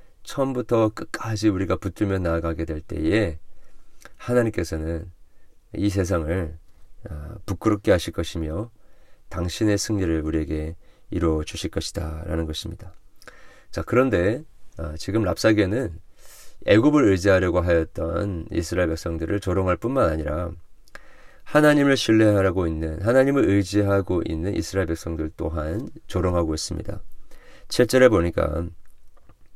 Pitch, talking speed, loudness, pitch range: 90 Hz, 290 characters per minute, -23 LUFS, 80-105 Hz